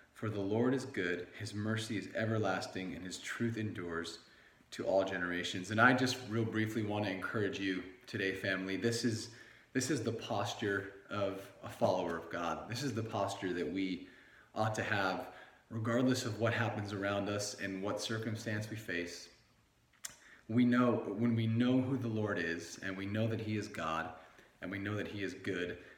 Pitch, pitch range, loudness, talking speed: 105 Hz, 95-115 Hz, -36 LUFS, 185 wpm